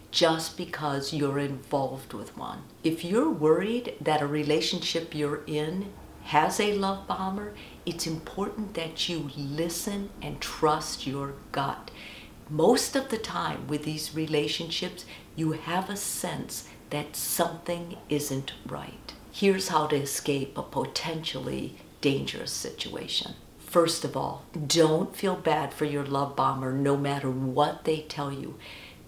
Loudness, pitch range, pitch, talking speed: -29 LUFS, 145-175 Hz, 155 Hz, 135 wpm